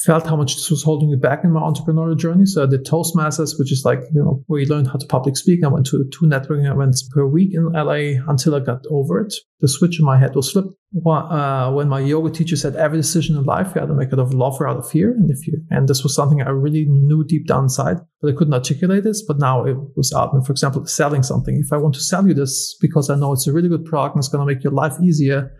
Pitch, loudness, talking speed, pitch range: 150 Hz, -17 LUFS, 285 wpm, 140-160 Hz